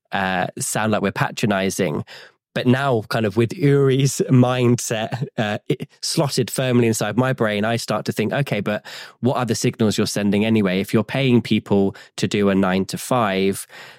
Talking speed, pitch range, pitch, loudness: 180 wpm, 105-125 Hz, 115 Hz, -20 LUFS